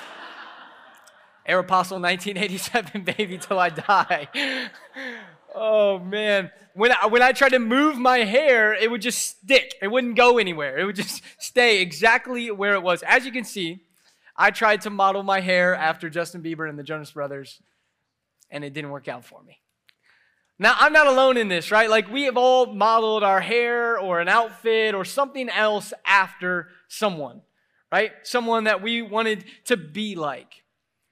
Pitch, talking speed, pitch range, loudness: 210 Hz, 170 wpm, 180-235 Hz, -21 LUFS